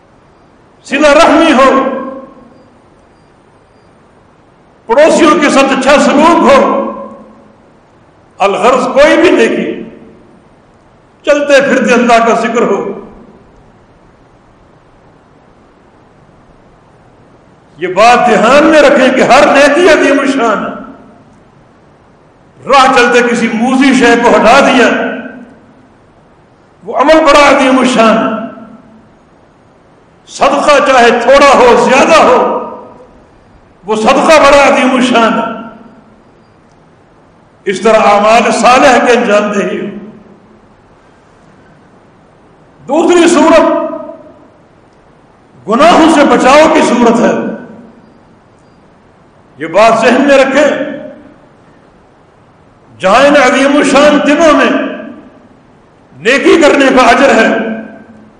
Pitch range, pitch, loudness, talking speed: 230-290 Hz, 265 Hz, -6 LUFS, 85 wpm